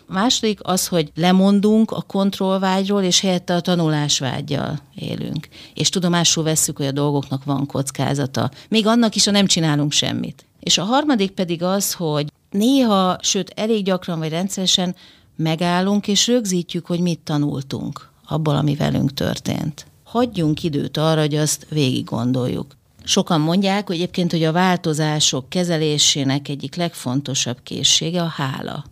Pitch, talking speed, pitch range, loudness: 170 Hz, 145 wpm, 145-190 Hz, -19 LUFS